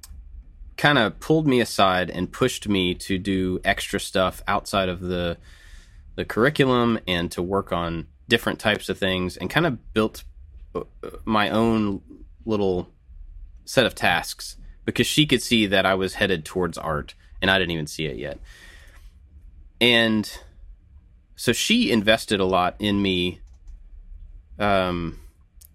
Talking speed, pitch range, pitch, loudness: 140 wpm, 80-100 Hz, 90 Hz, -22 LUFS